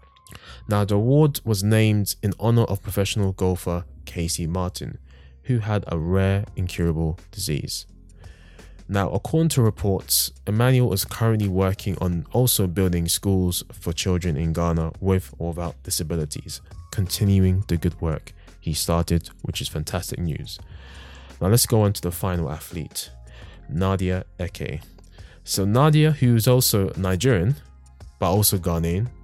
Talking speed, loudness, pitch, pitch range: 140 wpm, -23 LUFS, 90 Hz, 85-105 Hz